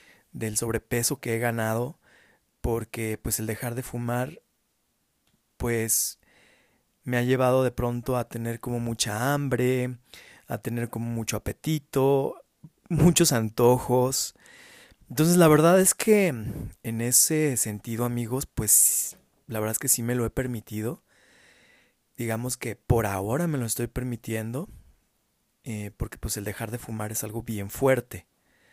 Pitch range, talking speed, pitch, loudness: 110-130 Hz, 140 wpm, 120 Hz, -25 LUFS